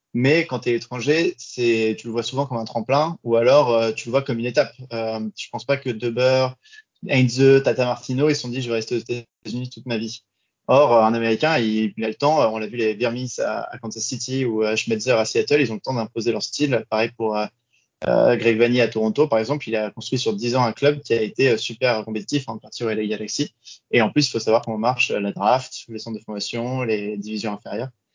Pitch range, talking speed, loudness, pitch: 110-130 Hz, 250 wpm, -21 LUFS, 120 Hz